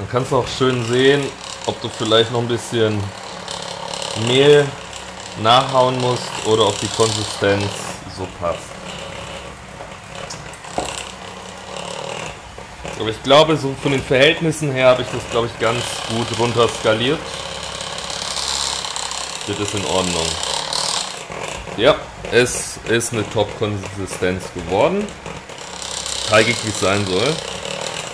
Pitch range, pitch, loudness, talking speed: 105-130 Hz, 115 Hz, -18 LUFS, 115 wpm